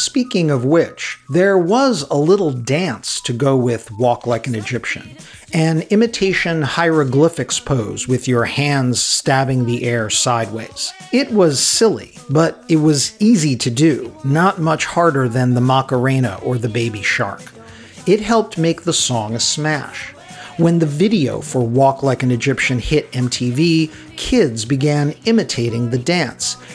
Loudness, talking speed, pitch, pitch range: -16 LUFS, 150 wpm, 135 Hz, 125-165 Hz